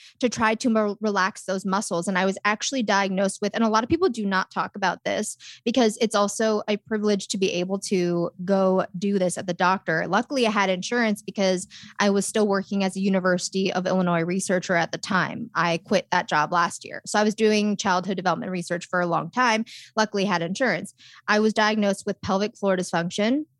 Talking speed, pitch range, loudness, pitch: 210 wpm, 185-215 Hz, -24 LUFS, 195 Hz